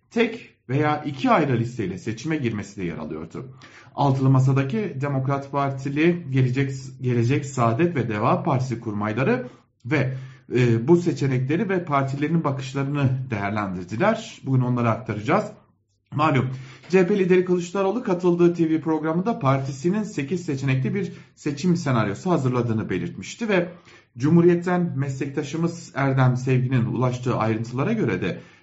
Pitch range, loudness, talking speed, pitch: 125-165 Hz, -23 LUFS, 115 wpm, 135 Hz